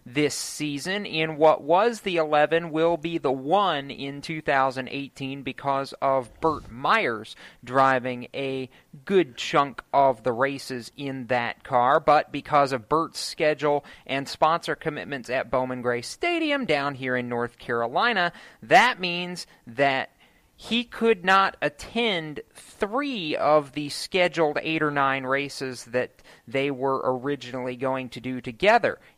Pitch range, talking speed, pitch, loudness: 130-165 Hz, 140 wpm, 140 Hz, -25 LUFS